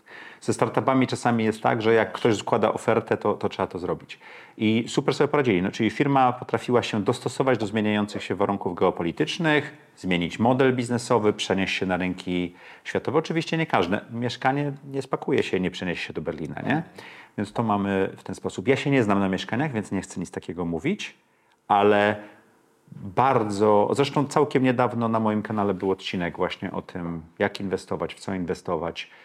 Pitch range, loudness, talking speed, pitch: 100-130 Hz, -25 LUFS, 180 wpm, 110 Hz